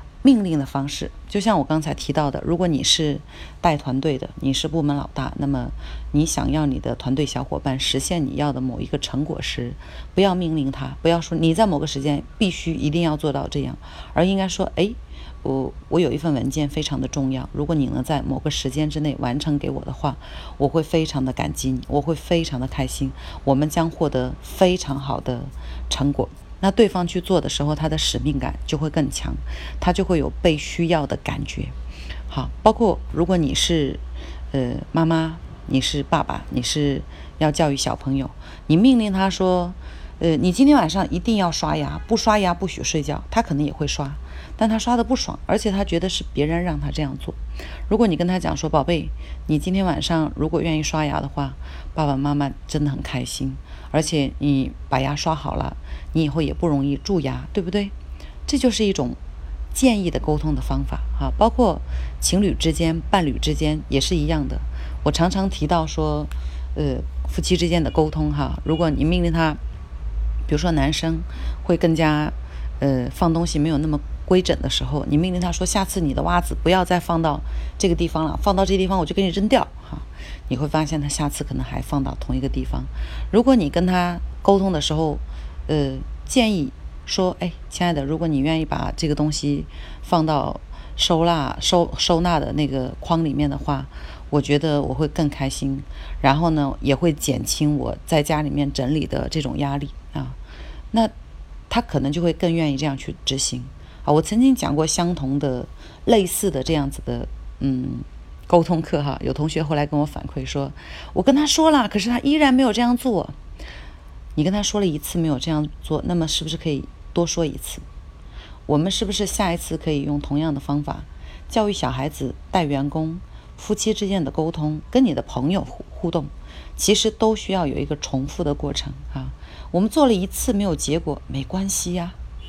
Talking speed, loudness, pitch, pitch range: 285 characters per minute, -22 LUFS, 150 Hz, 135-175 Hz